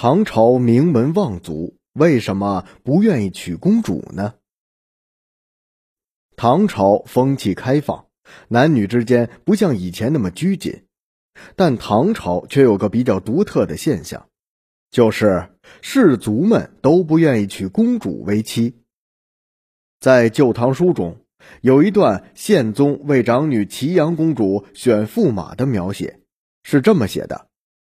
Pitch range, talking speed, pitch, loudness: 100-150 Hz, 190 characters per minute, 120 Hz, -17 LUFS